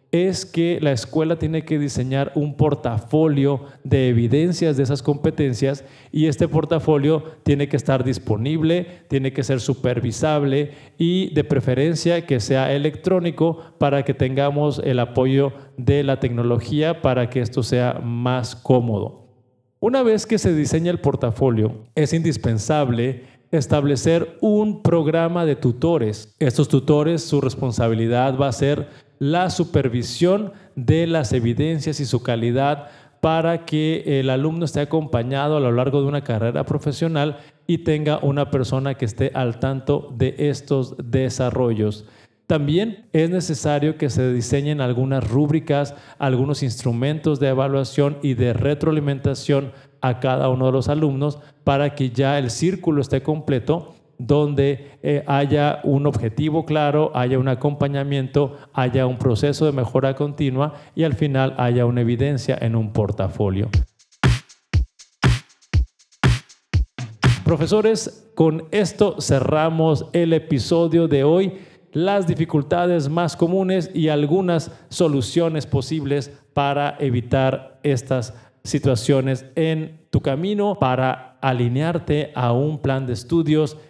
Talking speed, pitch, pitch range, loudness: 130 wpm, 145 Hz, 130-155 Hz, -20 LUFS